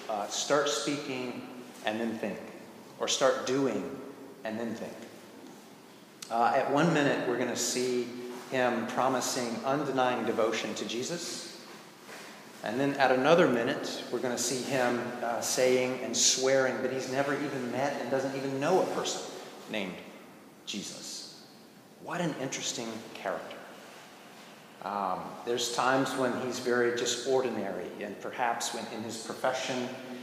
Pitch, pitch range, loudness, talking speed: 125 Hz, 120-130 Hz, -30 LUFS, 135 wpm